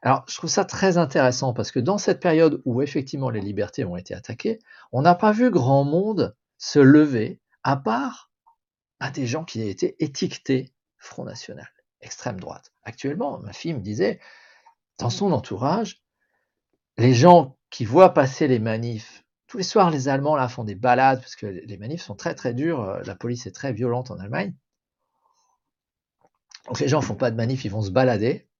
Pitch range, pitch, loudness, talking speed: 120-165 Hz, 135 Hz, -22 LUFS, 185 wpm